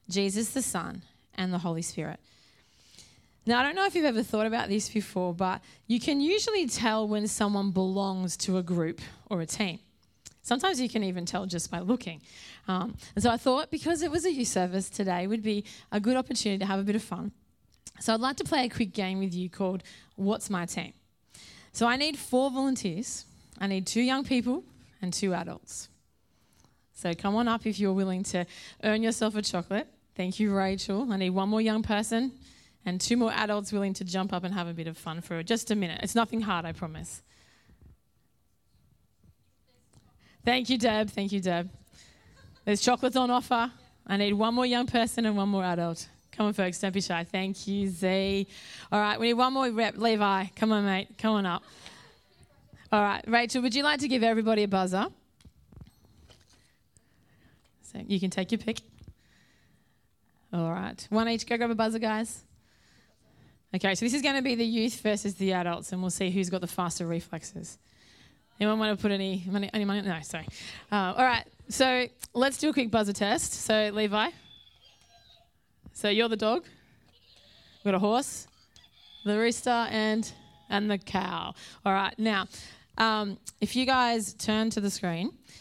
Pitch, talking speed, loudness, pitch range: 210 Hz, 190 wpm, -29 LUFS, 190-235 Hz